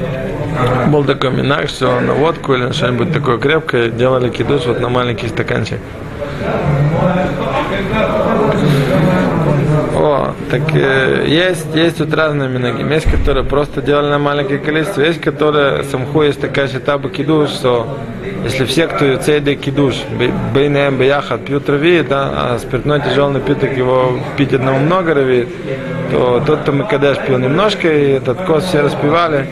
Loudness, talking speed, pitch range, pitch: -14 LUFS, 150 wpm, 130-150 Hz, 140 Hz